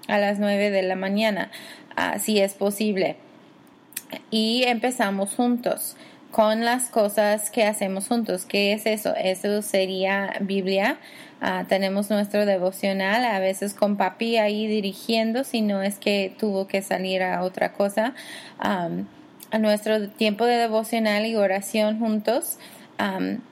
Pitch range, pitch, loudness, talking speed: 200-230 Hz, 215 Hz, -23 LUFS, 140 wpm